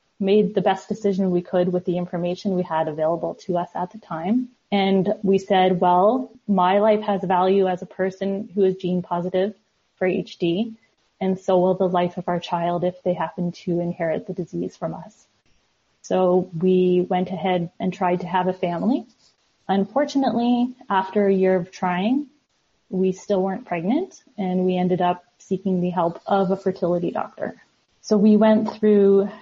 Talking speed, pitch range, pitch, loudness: 175 wpm, 180-205 Hz, 185 Hz, -22 LUFS